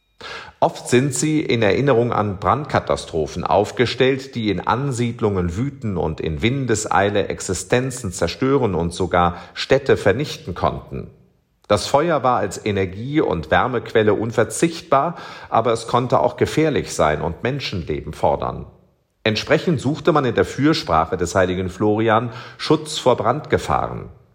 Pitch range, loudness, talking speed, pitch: 95-140 Hz, -20 LUFS, 125 wpm, 120 Hz